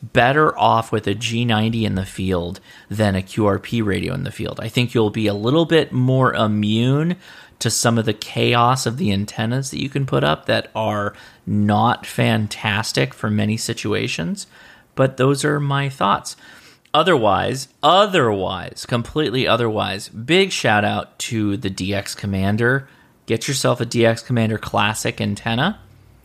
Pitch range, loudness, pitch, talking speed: 105-125 Hz, -19 LUFS, 115 Hz, 155 wpm